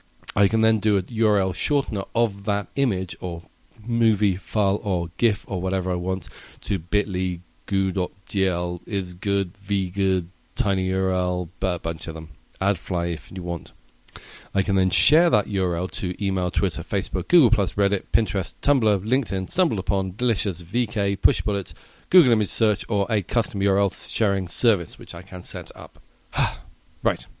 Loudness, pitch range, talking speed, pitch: -24 LUFS, 90-105 Hz, 150 wpm, 95 Hz